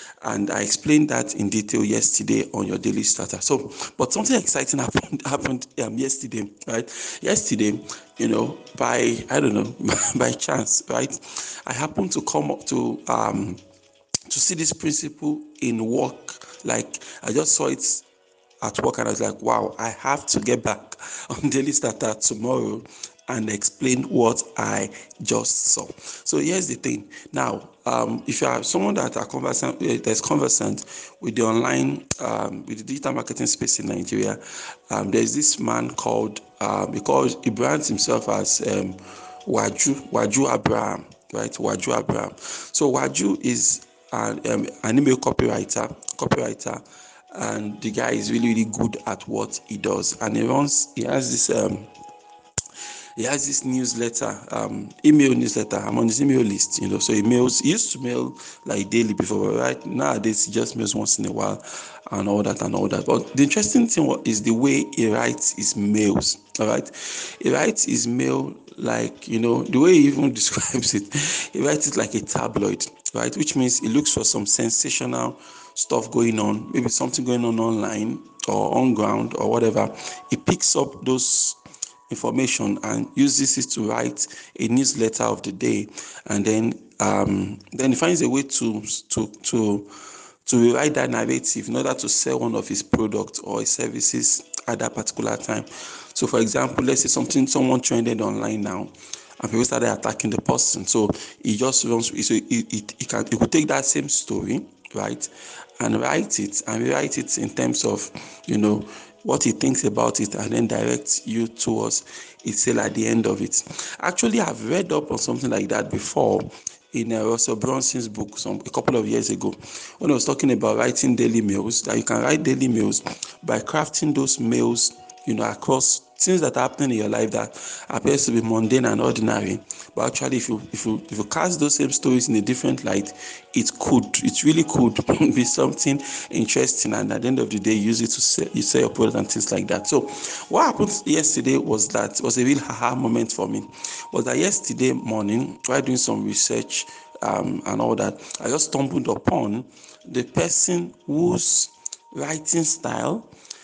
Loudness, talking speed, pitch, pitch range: -22 LUFS, 185 wpm, 115 Hz, 105-135 Hz